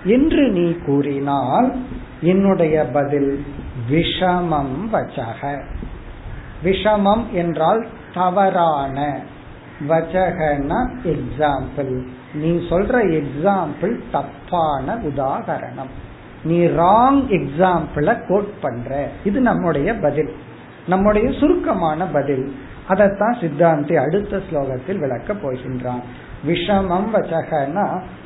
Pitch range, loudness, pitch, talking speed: 140-190 Hz, -19 LUFS, 165 Hz, 75 wpm